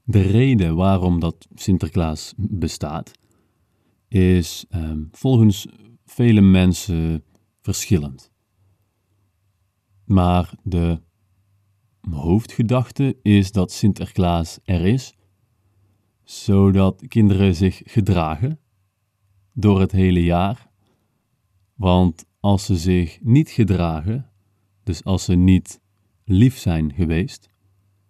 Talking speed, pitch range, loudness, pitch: 90 wpm, 90-110 Hz, -19 LUFS, 100 Hz